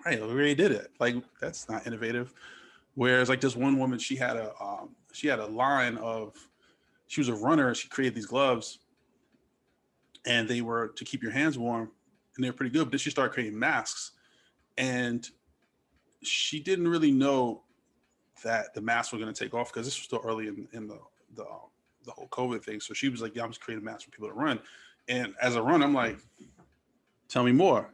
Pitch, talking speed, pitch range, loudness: 125 Hz, 210 wpm, 115-135 Hz, -29 LUFS